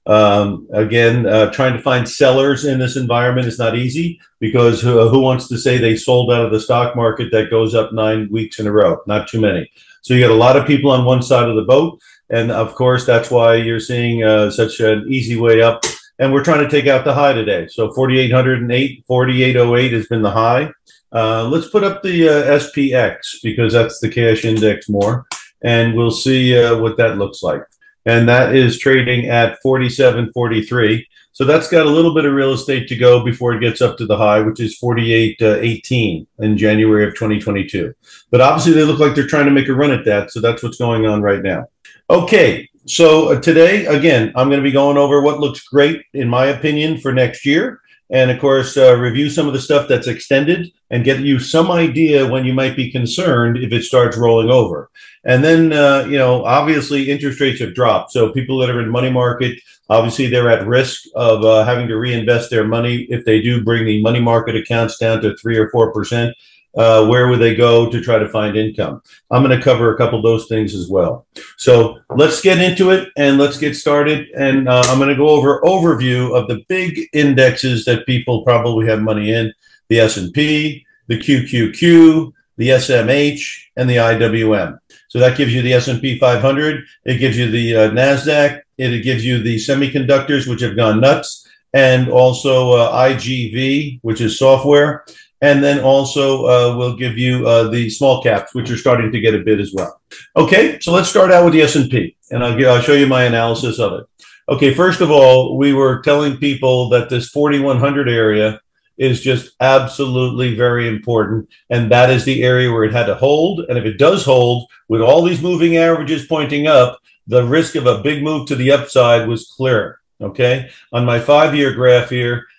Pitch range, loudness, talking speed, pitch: 115-140 Hz, -13 LUFS, 205 wpm, 125 Hz